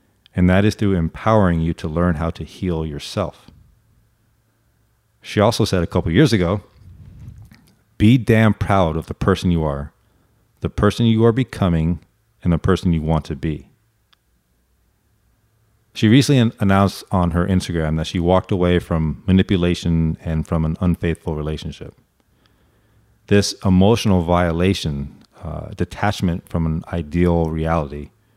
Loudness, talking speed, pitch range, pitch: -19 LUFS, 140 wpm, 85-110 Hz, 95 Hz